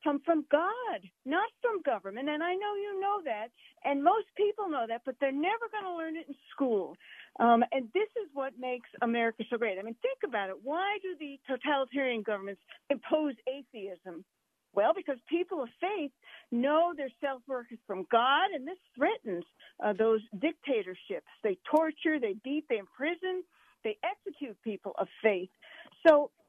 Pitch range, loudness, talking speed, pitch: 235-345 Hz, -32 LUFS, 170 wpm, 285 Hz